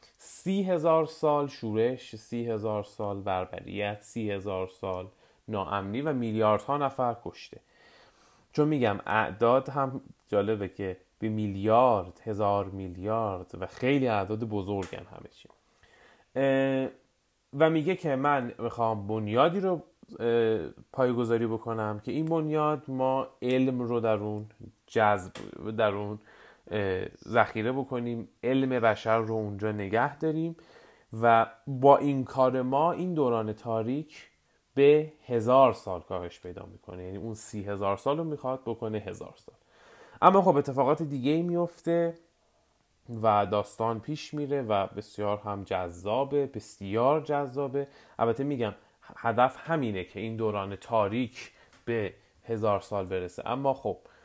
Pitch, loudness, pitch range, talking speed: 115 Hz, -29 LUFS, 105-140 Hz, 125 wpm